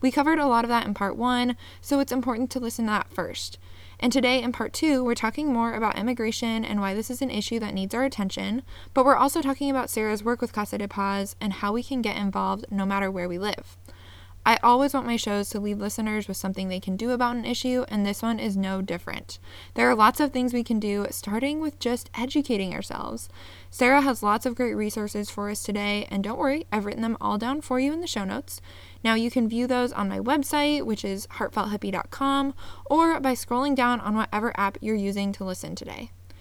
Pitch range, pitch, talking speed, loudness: 200-250 Hz, 220 Hz, 230 wpm, -26 LUFS